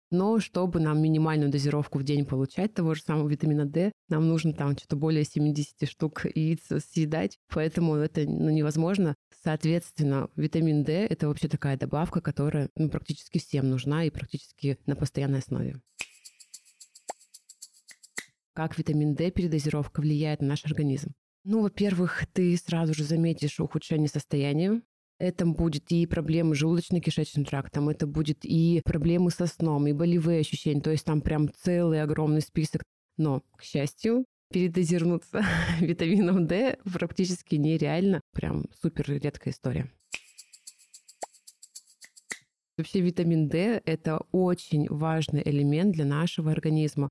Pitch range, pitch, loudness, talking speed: 150-170 Hz, 155 Hz, -28 LUFS, 130 wpm